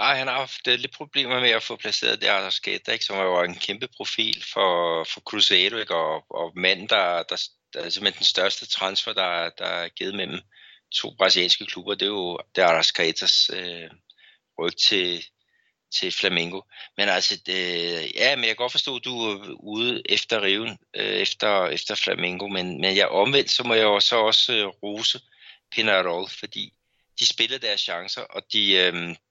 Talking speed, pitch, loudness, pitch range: 190 wpm, 100 Hz, -22 LUFS, 90-125 Hz